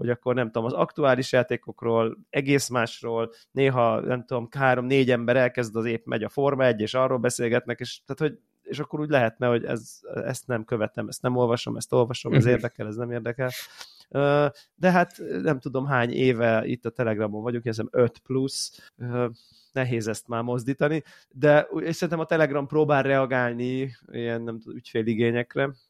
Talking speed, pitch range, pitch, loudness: 170 wpm, 115-135 Hz, 125 Hz, -25 LUFS